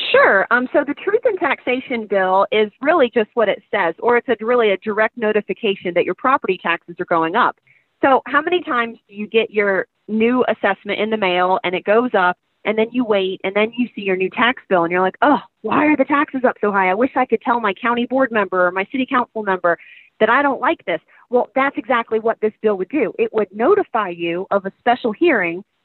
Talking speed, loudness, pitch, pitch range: 240 wpm, -18 LUFS, 220 Hz, 195-250 Hz